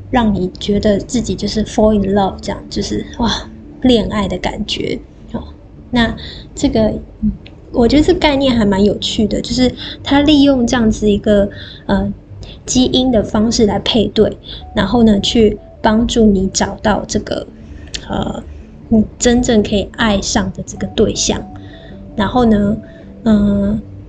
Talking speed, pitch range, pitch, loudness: 225 characters per minute, 200-235 Hz, 215 Hz, -14 LUFS